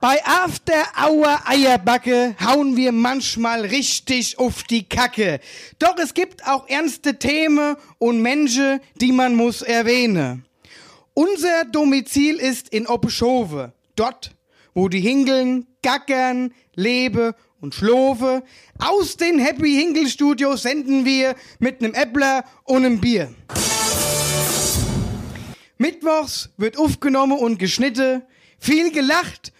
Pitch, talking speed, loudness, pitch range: 255 Hz, 105 wpm, -19 LUFS, 230-285 Hz